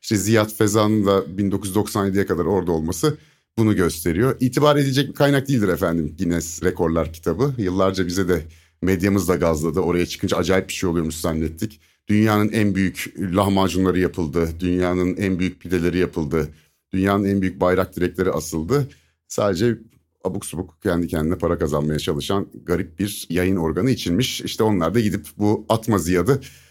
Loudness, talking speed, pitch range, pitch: -21 LUFS, 155 wpm, 85-105 Hz, 95 Hz